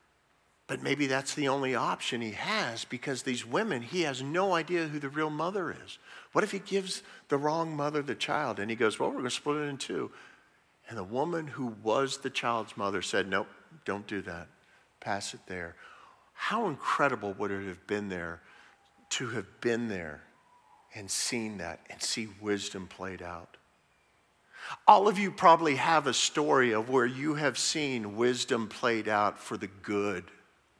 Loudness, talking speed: -30 LUFS, 180 wpm